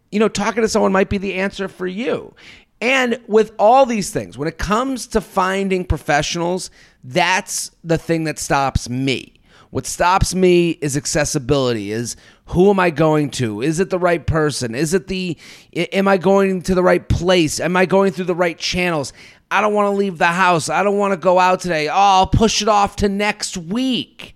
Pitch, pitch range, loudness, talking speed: 185 Hz, 155-200 Hz, -17 LUFS, 205 wpm